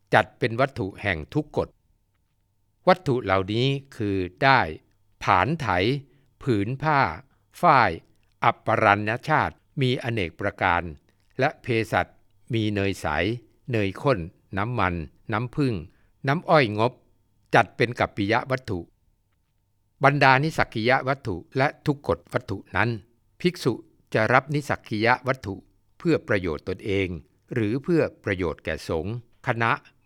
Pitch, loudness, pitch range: 110 Hz, -24 LUFS, 100-130 Hz